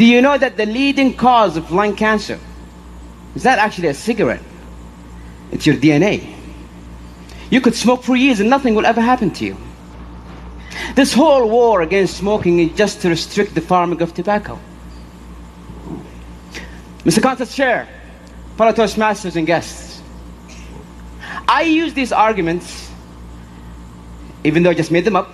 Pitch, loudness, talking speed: 160 Hz, -15 LUFS, 145 wpm